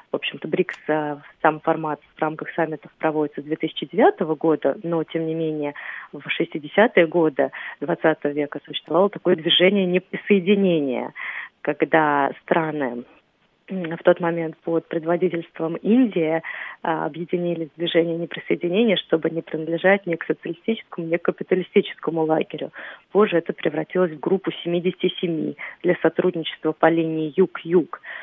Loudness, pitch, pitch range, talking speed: -22 LUFS, 165 Hz, 155-180 Hz, 120 wpm